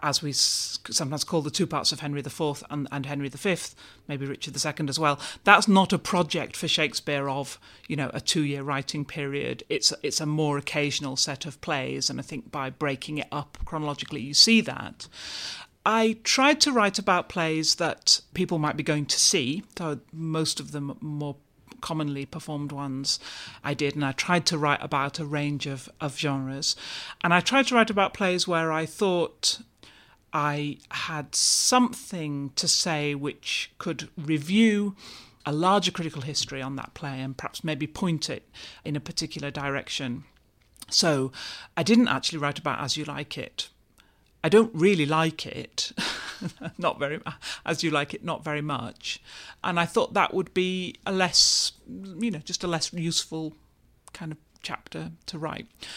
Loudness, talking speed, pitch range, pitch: -26 LUFS, 175 wpm, 145-175 Hz, 150 Hz